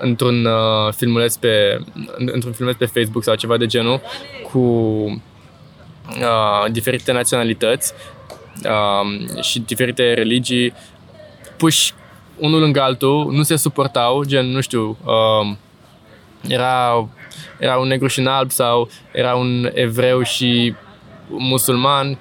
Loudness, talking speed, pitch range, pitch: -17 LUFS, 120 wpm, 115-130 Hz, 125 Hz